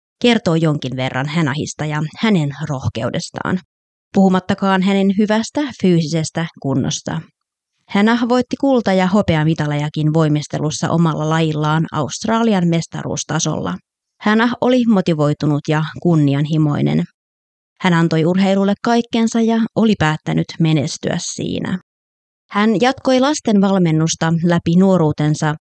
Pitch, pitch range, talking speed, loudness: 165 Hz, 150-200 Hz, 100 wpm, -17 LUFS